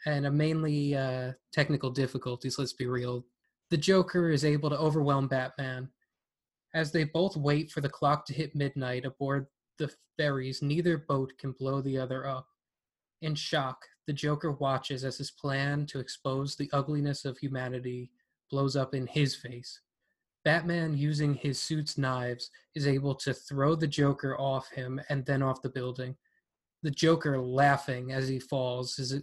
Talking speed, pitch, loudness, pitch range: 165 wpm, 140 Hz, -31 LUFS, 130-150 Hz